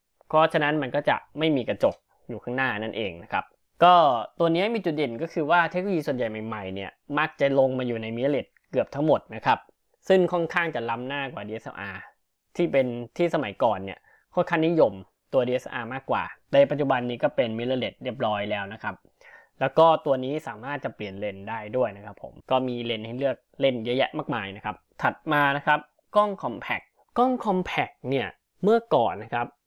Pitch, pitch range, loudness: 140 Hz, 120-165 Hz, -25 LUFS